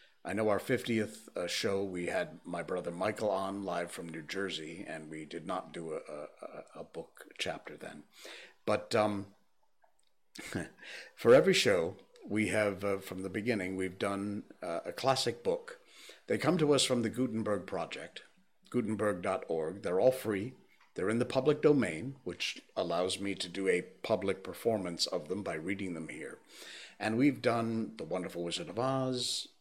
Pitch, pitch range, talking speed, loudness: 105 Hz, 95-125 Hz, 170 wpm, -34 LUFS